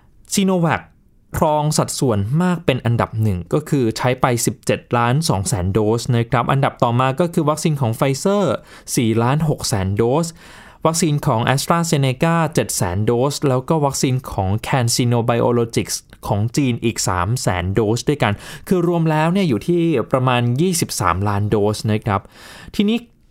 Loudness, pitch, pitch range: -18 LUFS, 130 Hz, 115-160 Hz